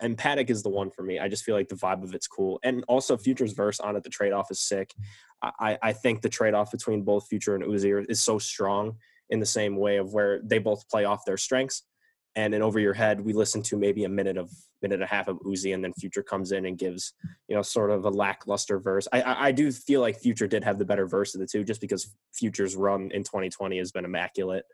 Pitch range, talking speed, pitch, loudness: 95-110 Hz, 260 wpm, 100 Hz, -27 LUFS